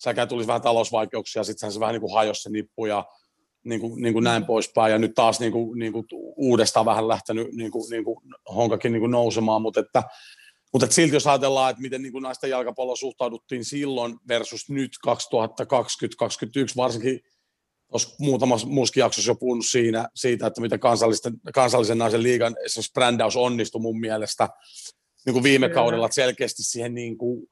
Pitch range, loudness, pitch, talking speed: 115-125 Hz, -23 LUFS, 115 Hz, 175 wpm